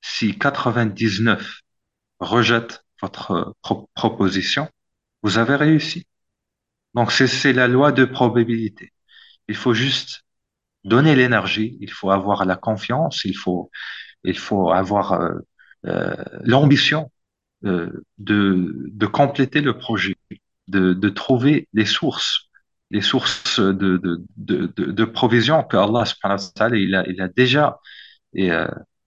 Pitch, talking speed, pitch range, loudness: 115 Hz, 130 wpm, 95-130 Hz, -19 LUFS